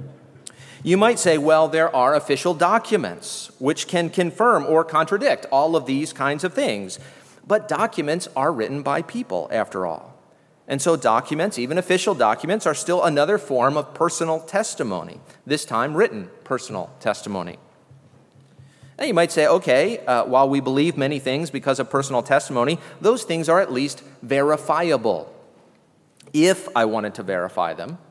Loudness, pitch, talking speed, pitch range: -21 LUFS, 155 Hz, 155 wpm, 135-180 Hz